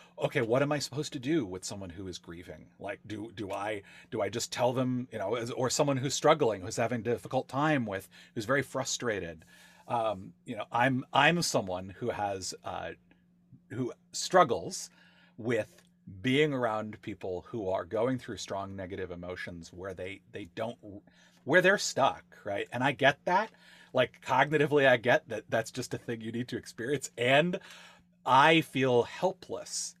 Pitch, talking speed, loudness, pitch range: 120 Hz, 175 wpm, -30 LUFS, 95-135 Hz